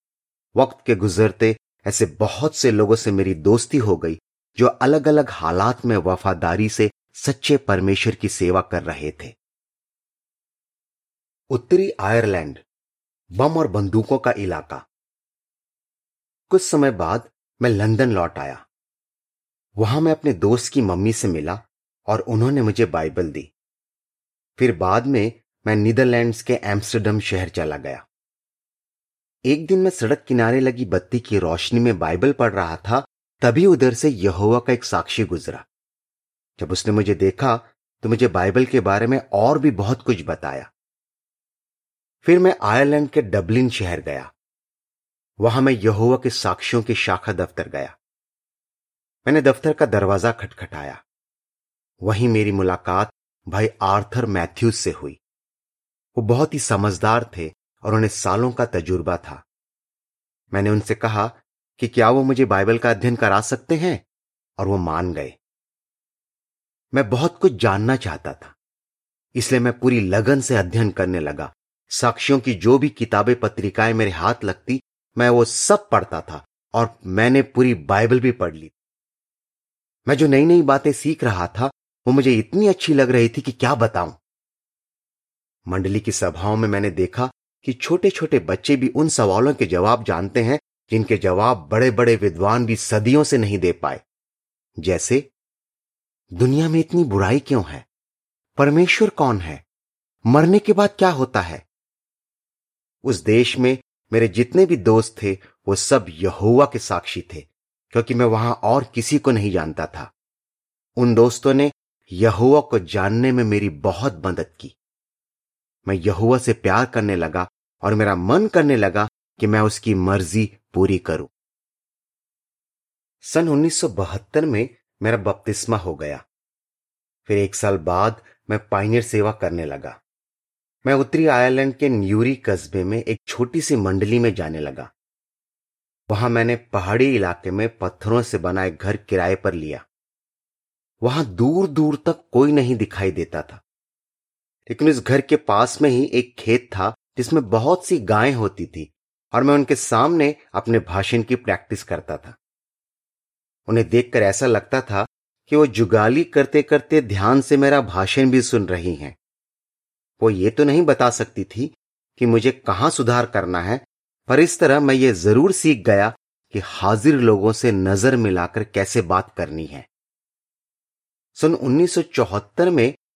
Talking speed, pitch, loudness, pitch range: 150 wpm, 115 Hz, -19 LUFS, 100-130 Hz